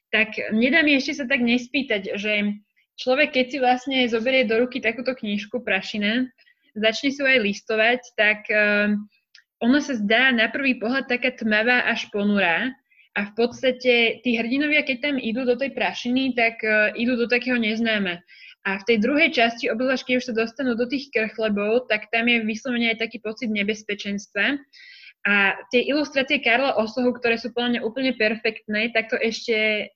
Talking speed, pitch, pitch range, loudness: 170 wpm, 235 Hz, 215-255 Hz, -21 LUFS